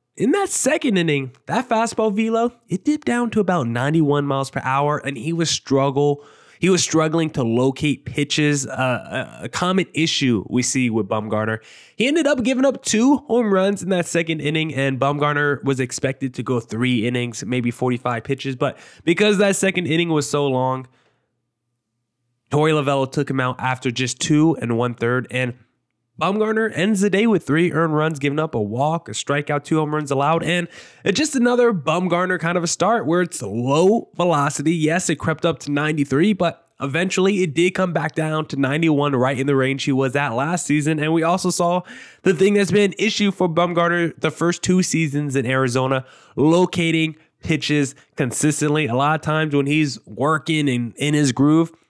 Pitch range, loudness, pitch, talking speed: 135-175 Hz, -20 LUFS, 155 Hz, 190 wpm